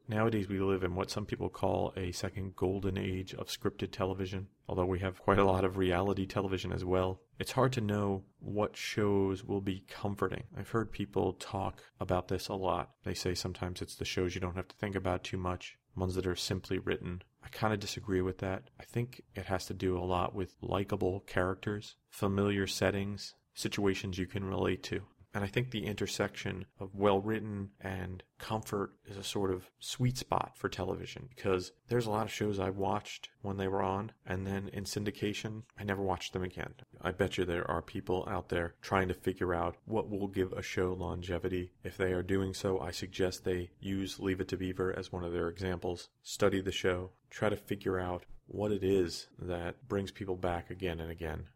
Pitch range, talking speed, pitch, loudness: 90-100 Hz, 205 wpm, 95 Hz, -36 LUFS